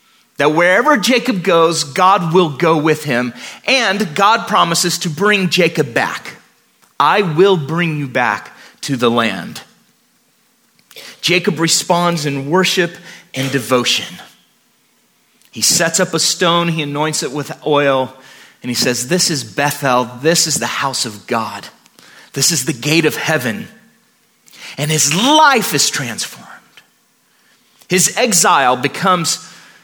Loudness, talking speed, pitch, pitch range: -14 LUFS, 135 wpm, 165 Hz, 145-185 Hz